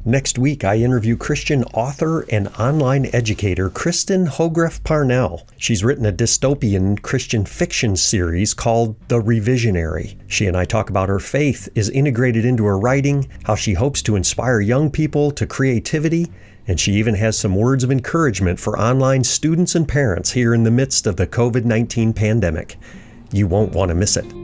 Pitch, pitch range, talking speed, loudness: 115 Hz, 105-135 Hz, 170 wpm, -18 LUFS